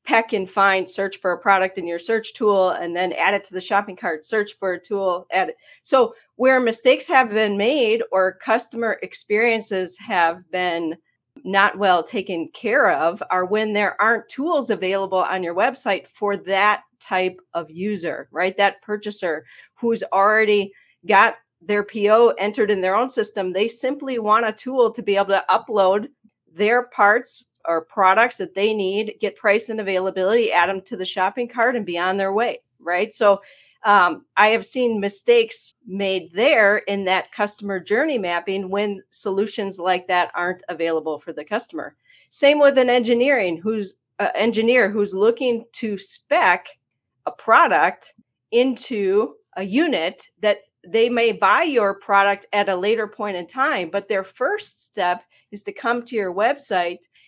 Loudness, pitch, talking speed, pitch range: -20 LUFS, 205 Hz, 170 wpm, 190-230 Hz